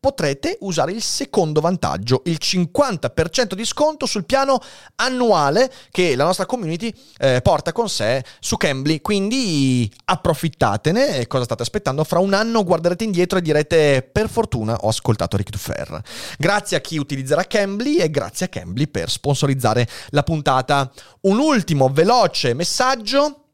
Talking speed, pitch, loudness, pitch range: 150 wpm, 170 Hz, -19 LUFS, 135-215 Hz